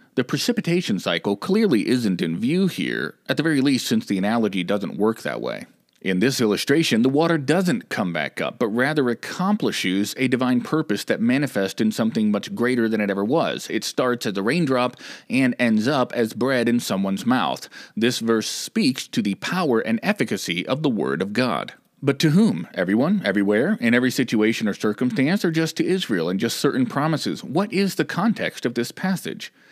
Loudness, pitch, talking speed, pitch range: -22 LUFS, 125 Hz, 190 wpm, 115-175 Hz